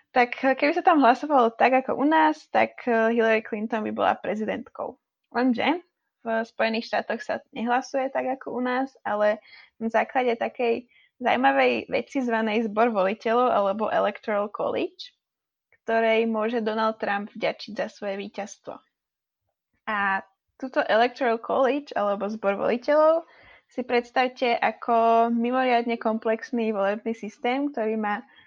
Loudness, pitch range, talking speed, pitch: -24 LUFS, 220-260 Hz, 130 wpm, 235 Hz